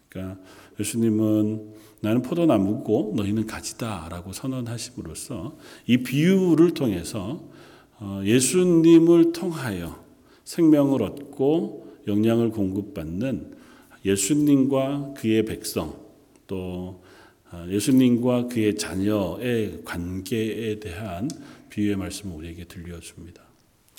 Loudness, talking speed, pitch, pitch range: -23 LUFS, 235 characters per minute, 110 Hz, 95-130 Hz